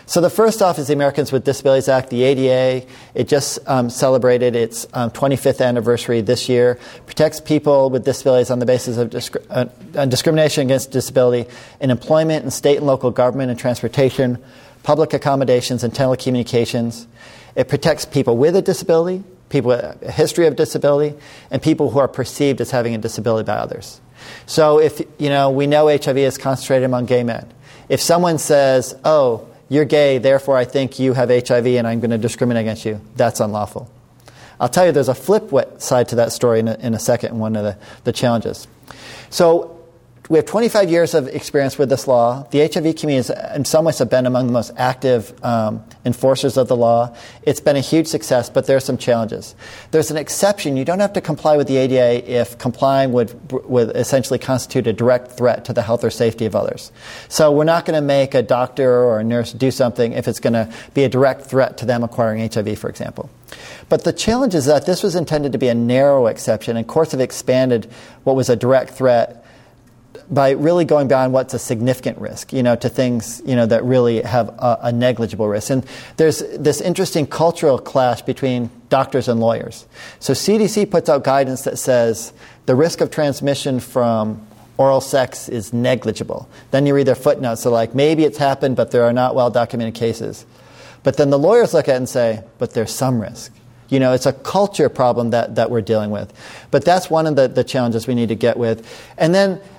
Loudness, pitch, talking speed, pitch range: -17 LUFS, 130 Hz, 205 wpm, 120-145 Hz